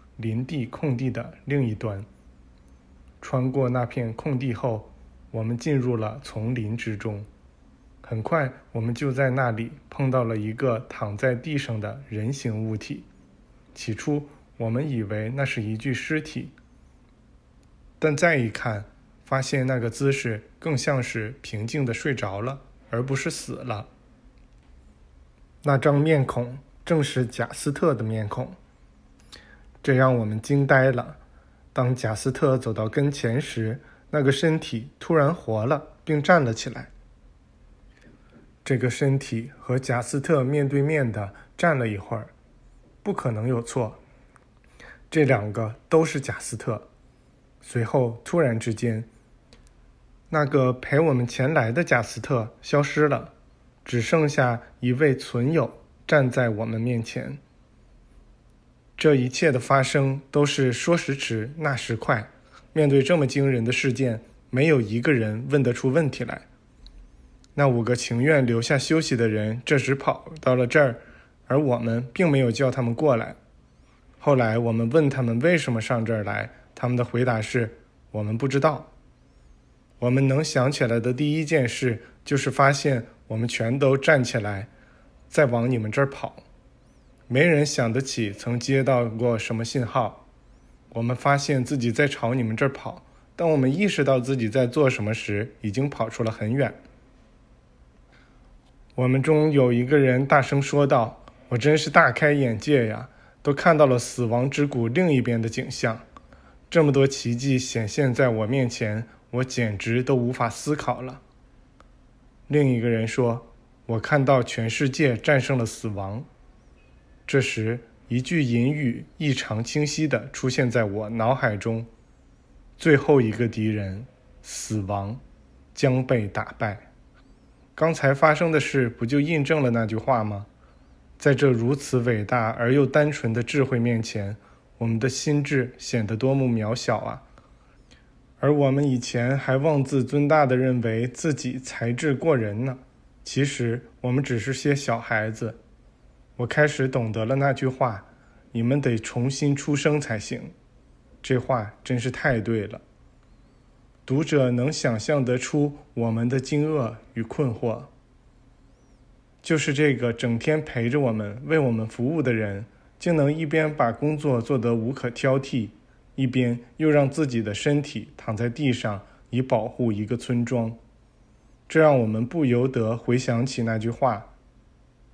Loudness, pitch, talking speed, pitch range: -24 LUFS, 125 Hz, 215 characters per minute, 115-140 Hz